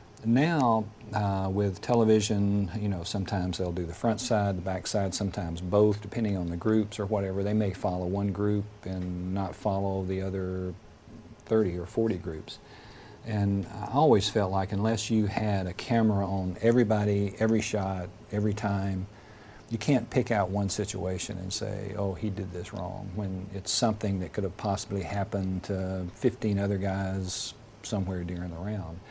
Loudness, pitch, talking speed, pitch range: -29 LUFS, 100 Hz, 170 wpm, 95-110 Hz